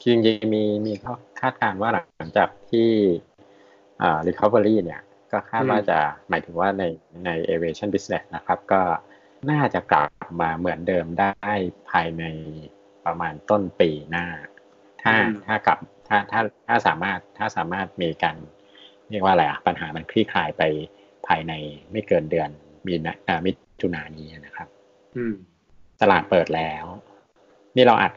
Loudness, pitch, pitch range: -23 LUFS, 95 Hz, 80-105 Hz